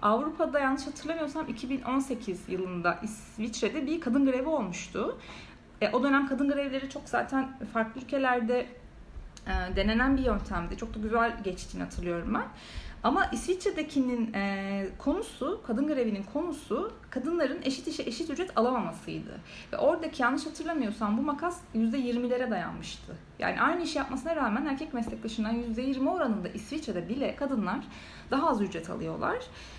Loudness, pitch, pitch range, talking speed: -31 LUFS, 255 Hz, 220-290 Hz, 135 wpm